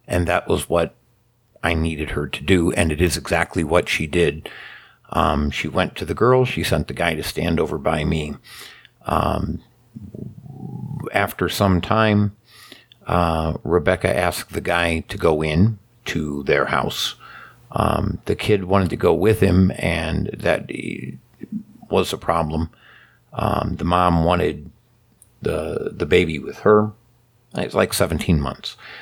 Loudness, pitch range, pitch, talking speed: -20 LUFS, 80-105 Hz, 90 Hz, 150 wpm